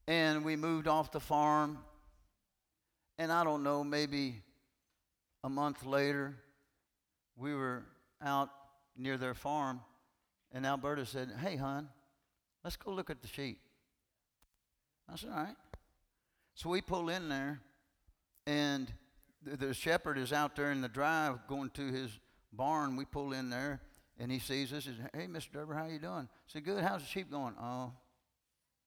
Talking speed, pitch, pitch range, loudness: 160 wpm, 140 Hz, 130-150 Hz, -38 LUFS